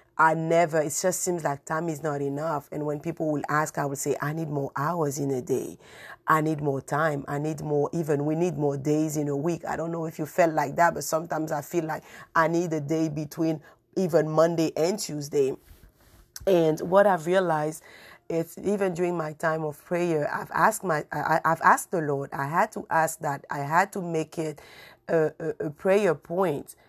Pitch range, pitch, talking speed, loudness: 150-170 Hz, 160 Hz, 215 wpm, -26 LUFS